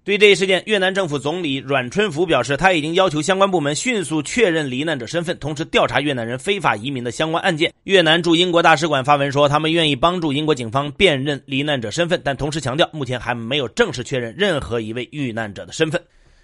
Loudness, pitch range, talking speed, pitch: -18 LUFS, 135-175 Hz, 370 characters per minute, 150 Hz